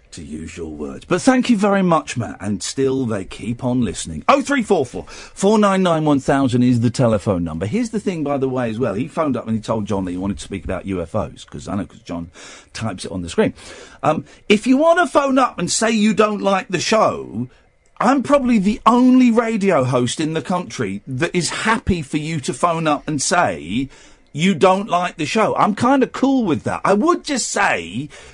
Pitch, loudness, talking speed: 170 Hz, -18 LUFS, 215 wpm